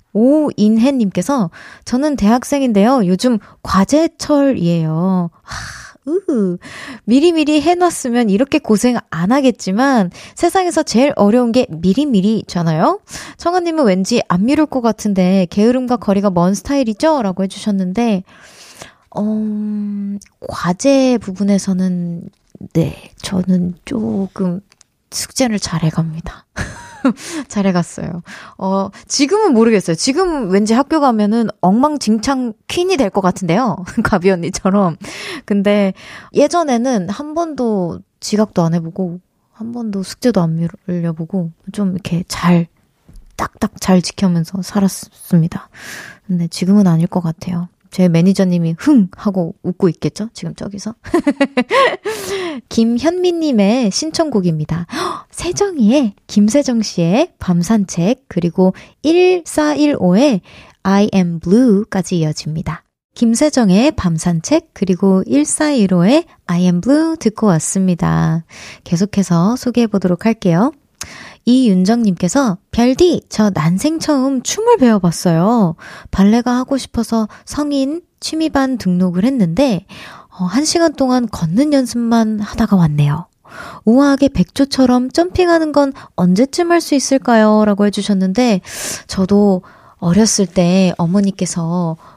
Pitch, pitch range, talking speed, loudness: 210 Hz, 185-270 Hz, 260 characters per minute, -15 LUFS